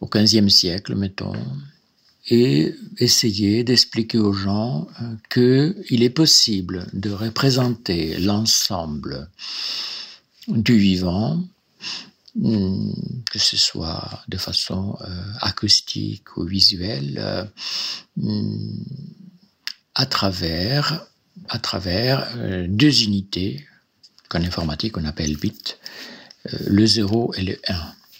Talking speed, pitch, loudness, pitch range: 85 wpm, 105 Hz, -20 LUFS, 95-125 Hz